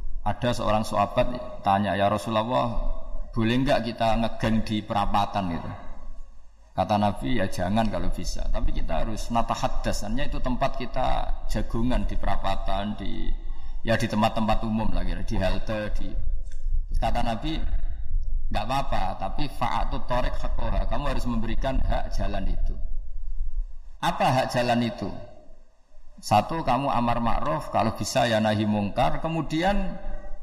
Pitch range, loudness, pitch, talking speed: 95-115 Hz, -27 LUFS, 105 Hz, 130 wpm